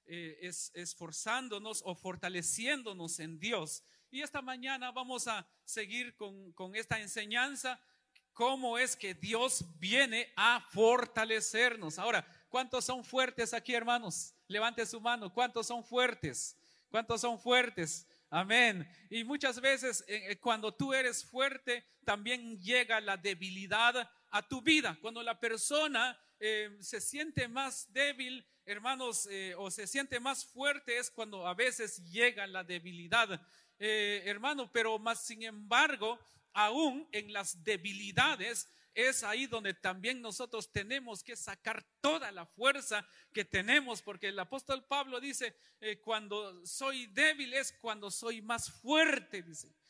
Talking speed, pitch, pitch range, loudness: 135 wpm, 230 Hz, 200-255 Hz, -34 LUFS